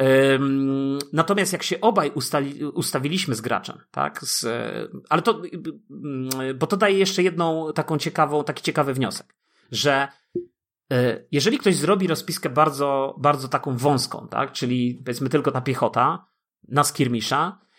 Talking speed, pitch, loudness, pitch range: 130 wpm, 145 Hz, -22 LUFS, 135-165 Hz